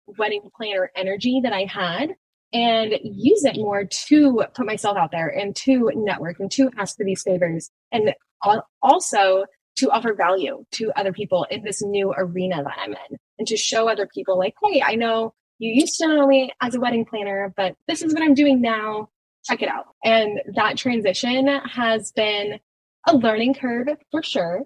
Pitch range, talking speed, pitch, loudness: 195-260 Hz, 185 wpm, 215 Hz, -21 LUFS